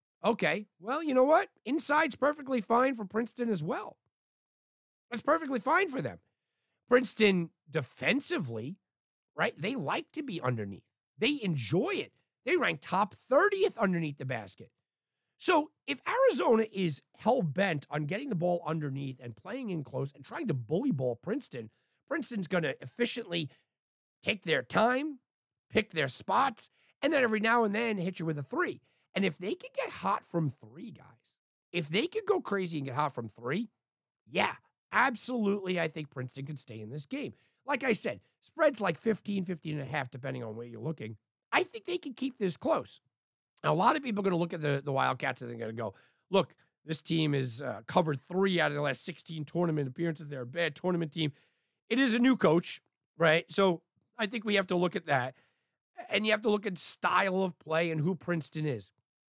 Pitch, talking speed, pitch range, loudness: 180 Hz, 195 wpm, 145-235 Hz, -31 LUFS